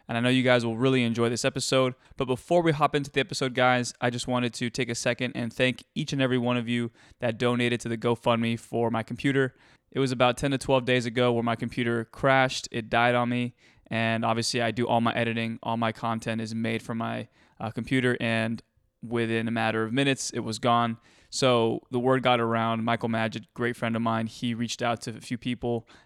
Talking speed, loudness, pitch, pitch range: 230 wpm, -27 LUFS, 120 Hz, 115-125 Hz